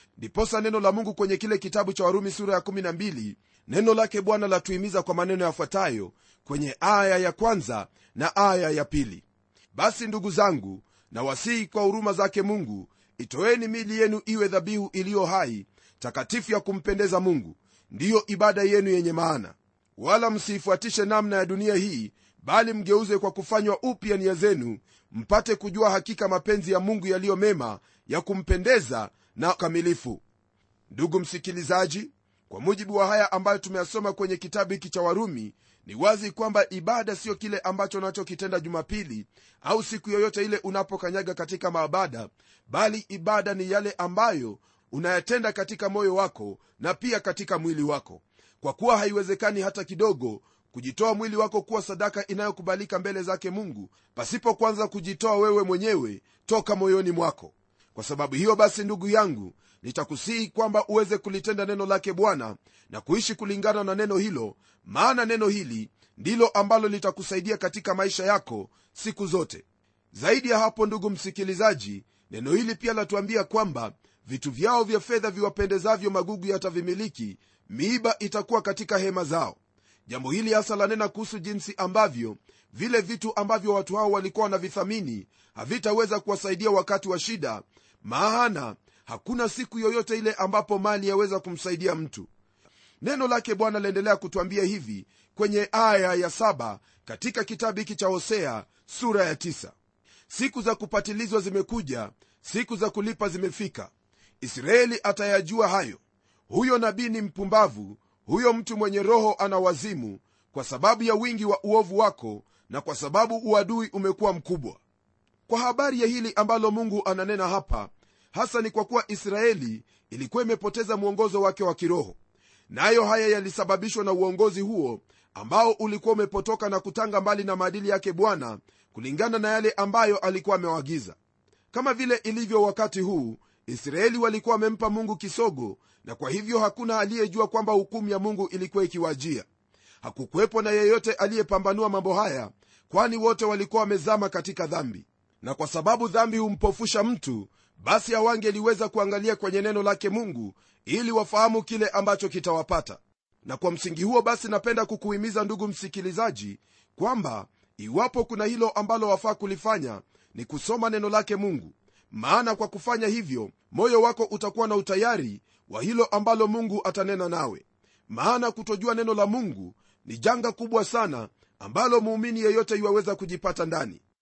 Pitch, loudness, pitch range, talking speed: 200 Hz, -26 LUFS, 180-220 Hz, 145 wpm